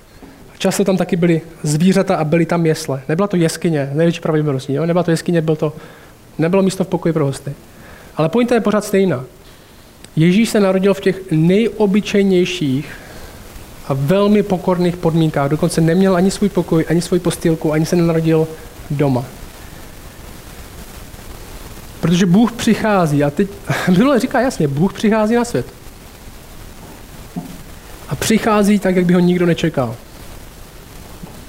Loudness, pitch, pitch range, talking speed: -16 LUFS, 170 Hz, 155-195 Hz, 140 wpm